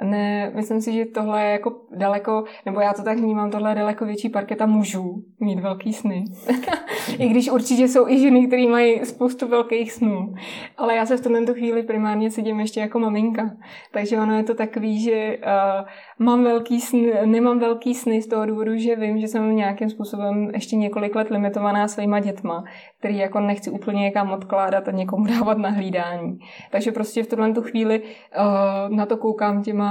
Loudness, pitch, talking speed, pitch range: -21 LUFS, 215 Hz, 185 wpm, 205-230 Hz